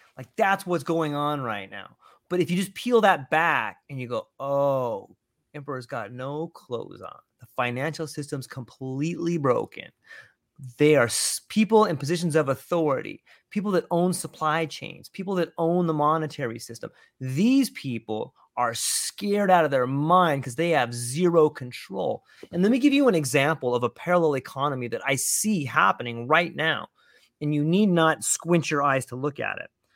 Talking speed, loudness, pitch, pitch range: 175 wpm, -24 LUFS, 155 Hz, 130-175 Hz